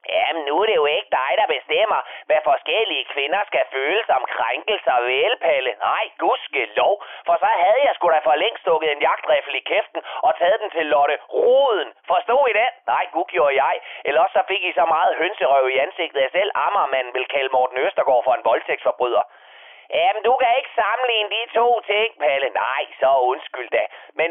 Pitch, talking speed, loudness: 210 Hz, 195 wpm, -19 LUFS